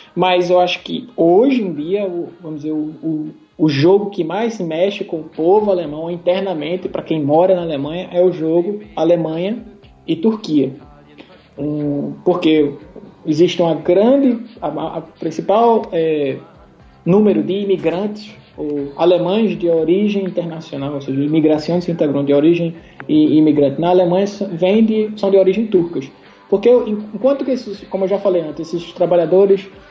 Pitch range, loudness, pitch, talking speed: 160-195 Hz, -16 LUFS, 175 Hz, 155 wpm